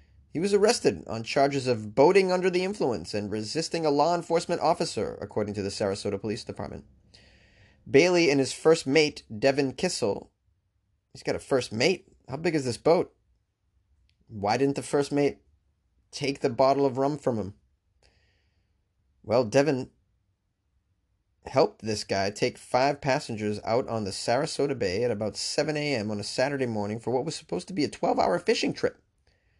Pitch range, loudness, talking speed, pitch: 95-145 Hz, -27 LUFS, 170 wpm, 115 Hz